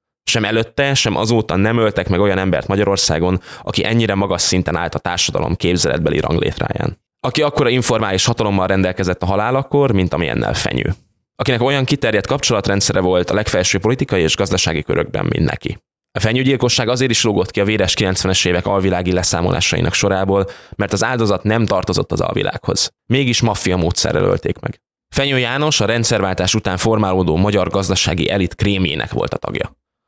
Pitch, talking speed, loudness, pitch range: 100 Hz, 160 wpm, -16 LUFS, 95-115 Hz